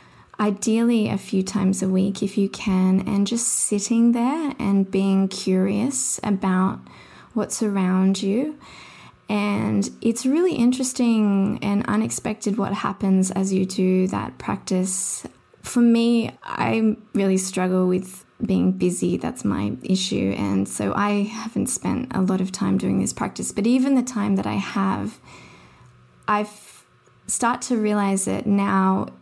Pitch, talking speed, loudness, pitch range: 200 Hz, 140 wpm, -22 LUFS, 190-225 Hz